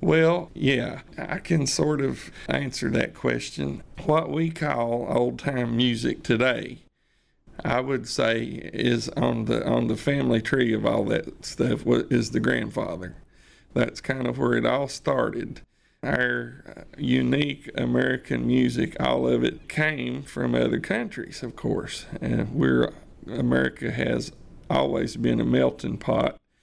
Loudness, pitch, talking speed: -25 LUFS, 120 Hz, 135 wpm